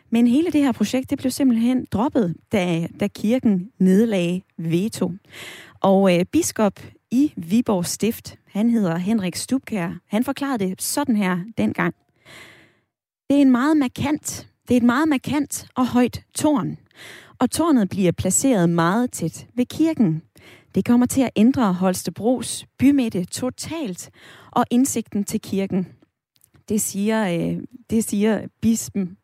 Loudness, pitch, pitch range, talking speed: -21 LUFS, 220 Hz, 185-255 Hz, 140 wpm